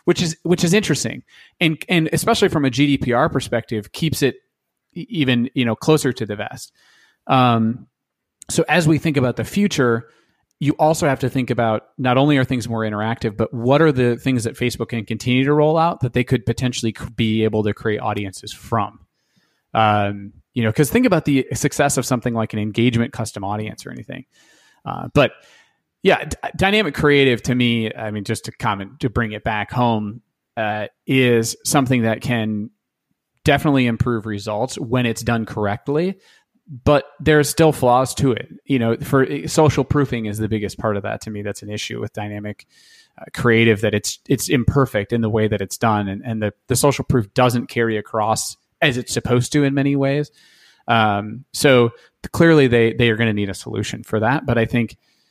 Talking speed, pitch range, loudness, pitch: 195 wpm, 110-140 Hz, -19 LUFS, 120 Hz